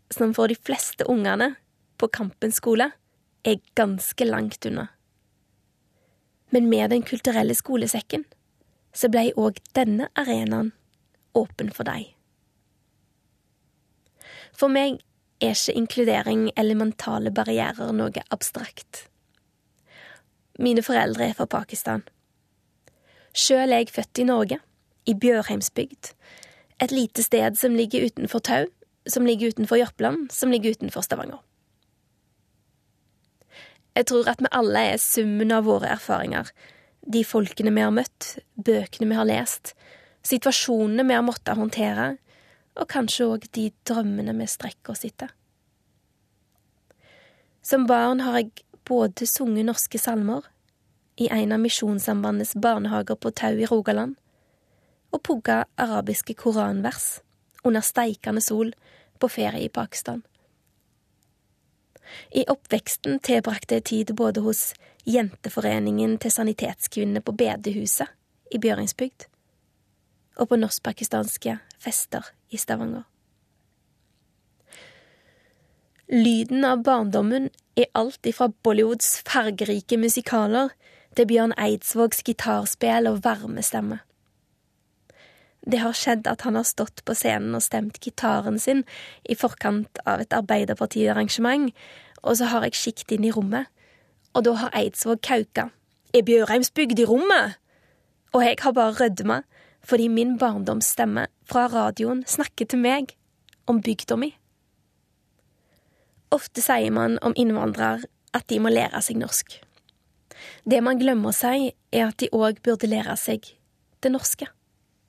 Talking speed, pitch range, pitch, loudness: 120 wpm, 215-245 Hz, 230 Hz, -23 LUFS